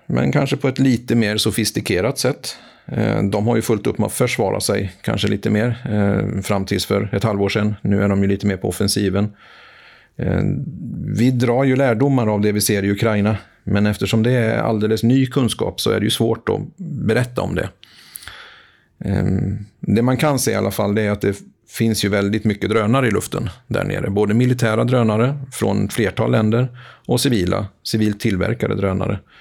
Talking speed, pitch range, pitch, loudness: 185 wpm, 100-120 Hz, 110 Hz, -19 LUFS